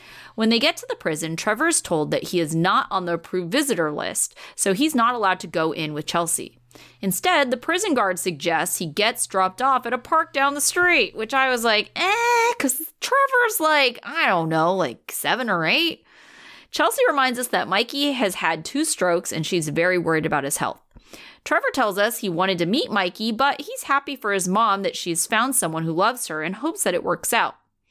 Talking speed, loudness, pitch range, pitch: 215 wpm, -21 LUFS, 170-275 Hz, 210 Hz